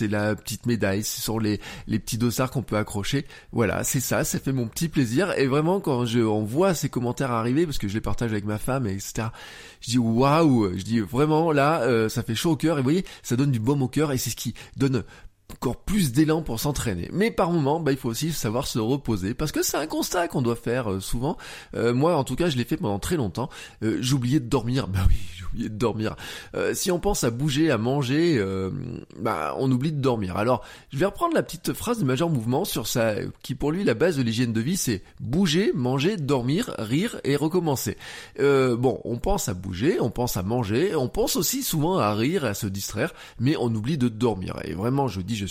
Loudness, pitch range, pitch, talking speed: -25 LUFS, 110-150 Hz, 125 Hz, 245 wpm